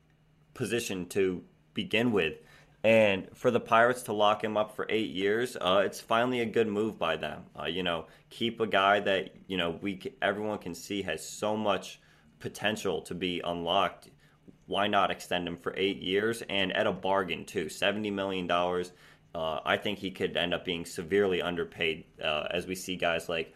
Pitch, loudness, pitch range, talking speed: 100 Hz, -30 LUFS, 90-110 Hz, 190 wpm